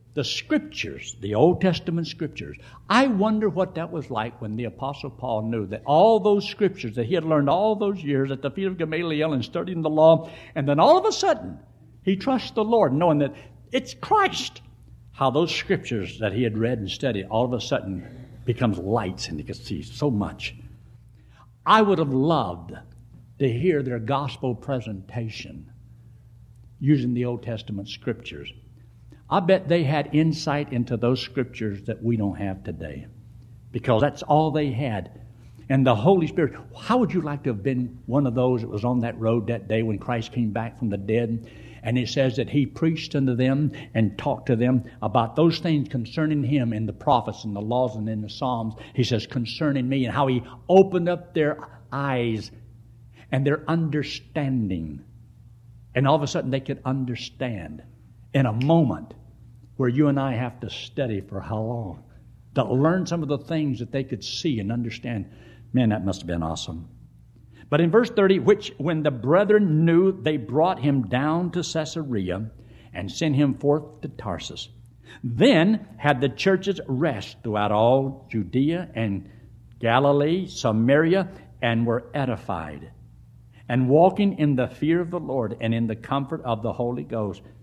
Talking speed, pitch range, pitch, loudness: 180 wpm, 115-150 Hz, 125 Hz, -24 LUFS